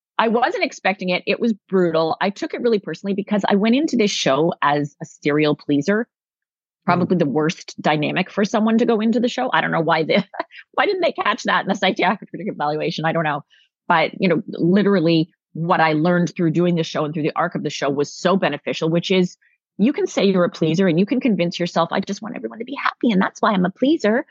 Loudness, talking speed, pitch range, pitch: -19 LUFS, 240 wpm, 160-215 Hz, 185 Hz